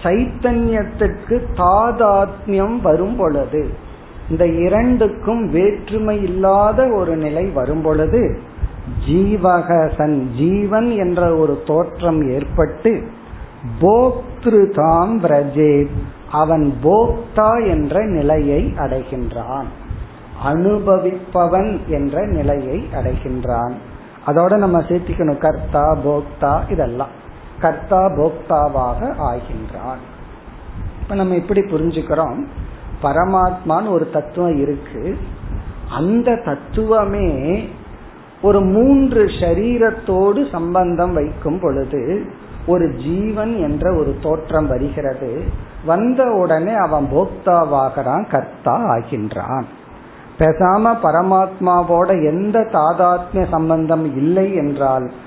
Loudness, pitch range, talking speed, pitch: -16 LUFS, 145-200 Hz, 75 wpm, 170 Hz